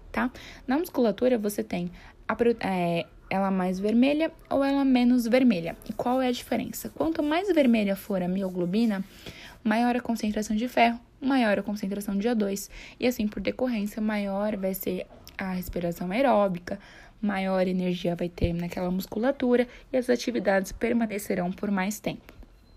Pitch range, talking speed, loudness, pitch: 190-245 Hz, 155 wpm, -27 LUFS, 215 Hz